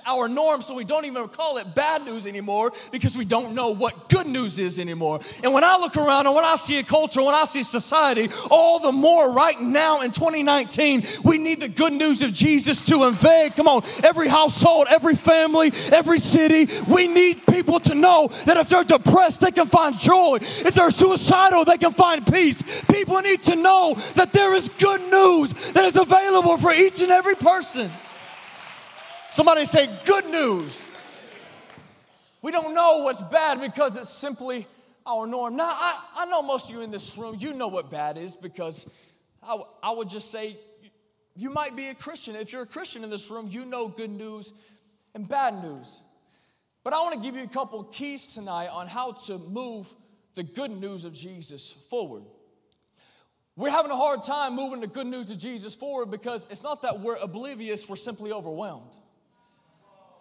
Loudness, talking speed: -19 LUFS, 190 wpm